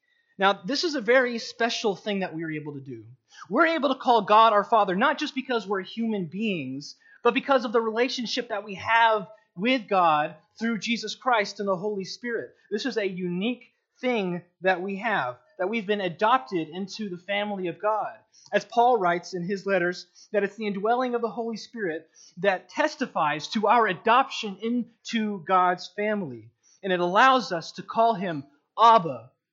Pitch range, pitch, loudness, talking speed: 185-235 Hz, 210 Hz, -25 LUFS, 185 wpm